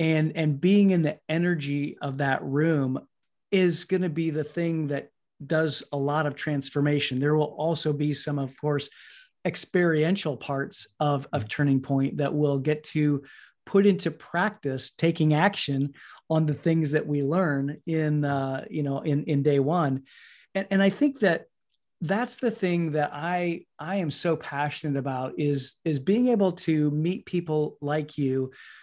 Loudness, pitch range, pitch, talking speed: -26 LUFS, 145-170 Hz, 150 Hz, 170 wpm